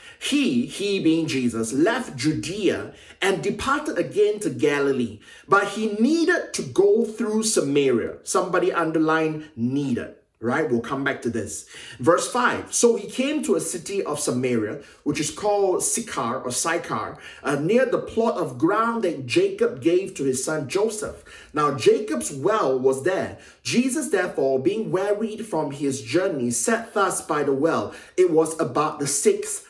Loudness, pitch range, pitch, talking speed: -23 LUFS, 145-235 Hz, 185 Hz, 160 wpm